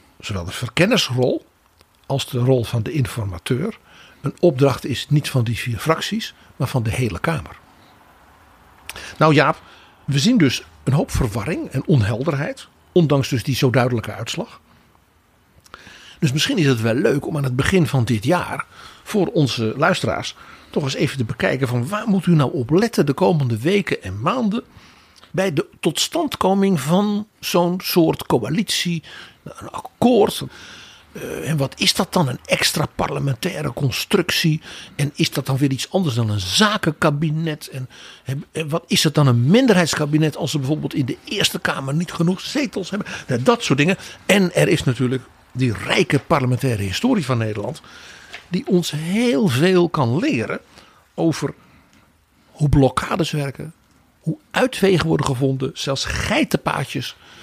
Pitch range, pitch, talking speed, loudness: 130-180 Hz, 145 Hz, 155 wpm, -19 LUFS